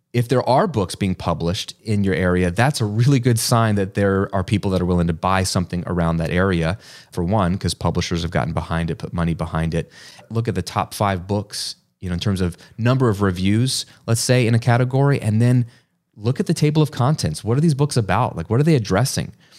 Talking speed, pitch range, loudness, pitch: 235 wpm, 90-125 Hz, -20 LUFS, 105 Hz